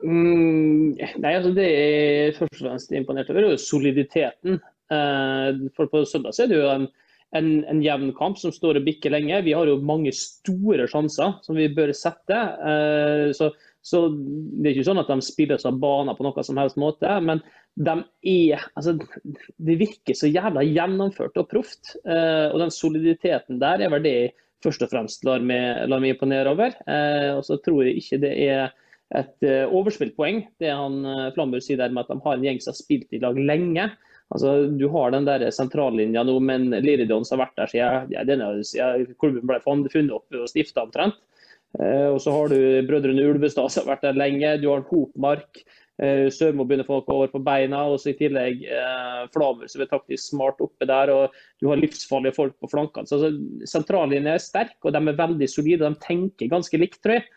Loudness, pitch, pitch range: -22 LUFS, 145 Hz, 135-160 Hz